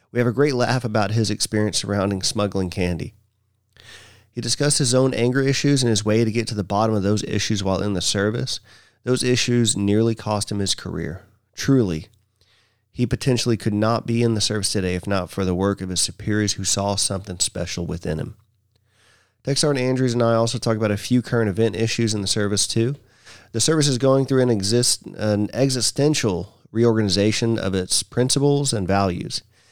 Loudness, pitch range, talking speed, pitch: -21 LUFS, 100-120 Hz, 190 wpm, 110 Hz